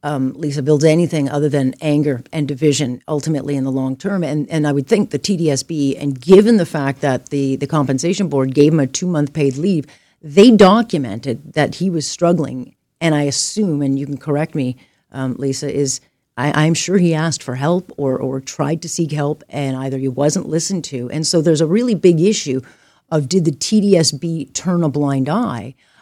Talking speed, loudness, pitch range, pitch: 205 wpm, -17 LUFS, 140-170 Hz, 150 Hz